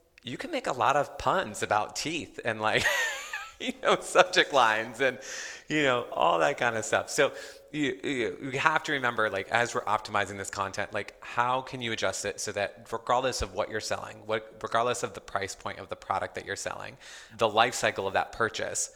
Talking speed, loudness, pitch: 210 wpm, -29 LUFS, 120 Hz